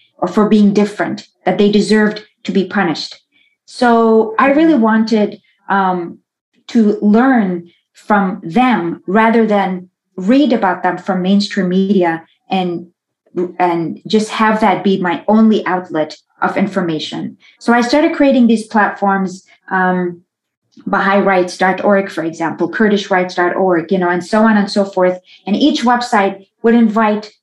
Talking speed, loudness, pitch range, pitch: 140 wpm, -14 LUFS, 185-220 Hz, 200 Hz